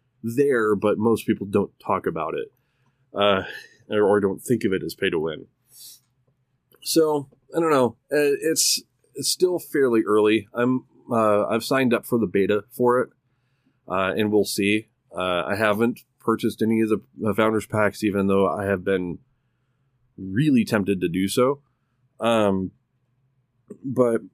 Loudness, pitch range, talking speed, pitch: -22 LUFS, 105-130 Hz, 155 wpm, 120 Hz